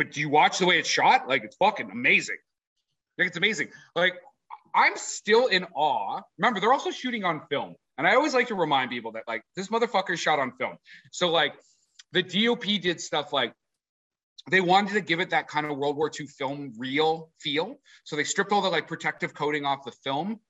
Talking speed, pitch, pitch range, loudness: 215 wpm, 165 Hz, 150-195 Hz, -25 LUFS